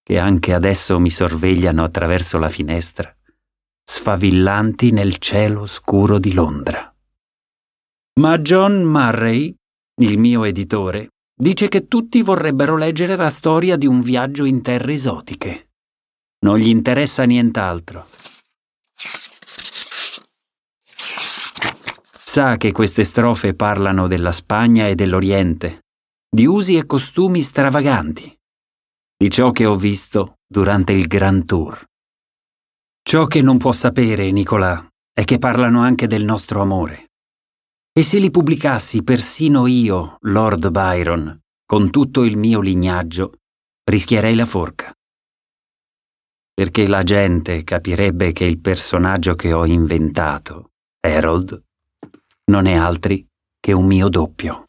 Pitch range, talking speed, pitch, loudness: 90-125 Hz, 115 wpm, 100 Hz, -16 LUFS